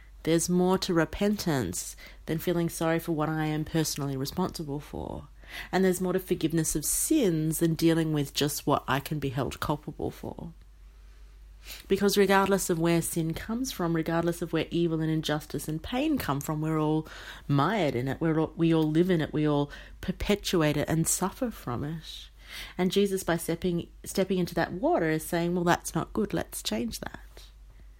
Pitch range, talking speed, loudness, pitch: 150-180 Hz, 185 wpm, -28 LUFS, 165 Hz